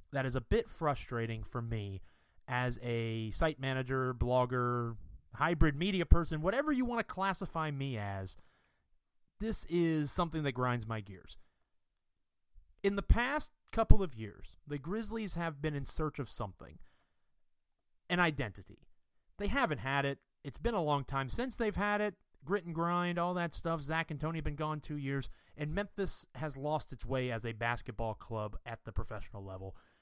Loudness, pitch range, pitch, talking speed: -36 LUFS, 110-170 Hz, 135 Hz, 170 wpm